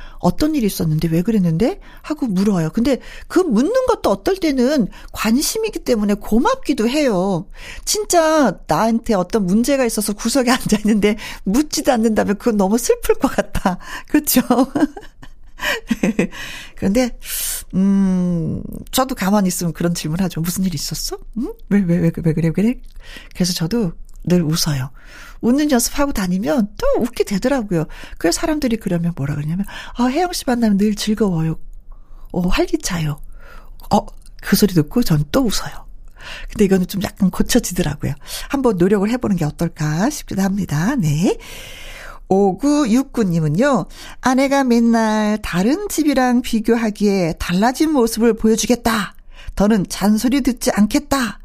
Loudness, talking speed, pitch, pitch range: -18 LUFS, 310 characters per minute, 220 Hz, 185-255 Hz